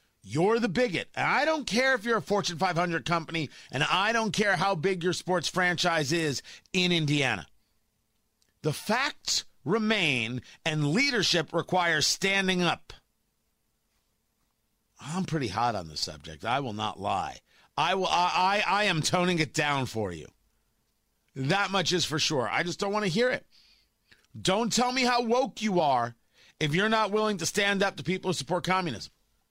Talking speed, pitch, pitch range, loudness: 175 wpm, 175 Hz, 135-200 Hz, -27 LUFS